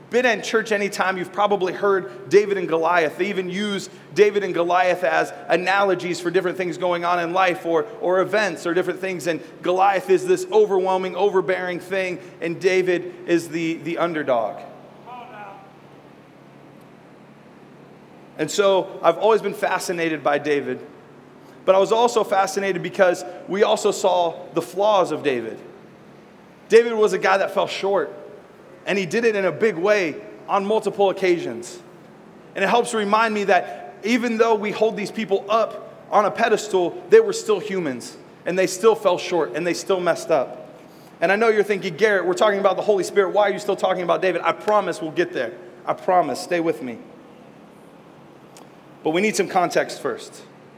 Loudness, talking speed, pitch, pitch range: -21 LUFS, 175 wpm, 190 Hz, 180-210 Hz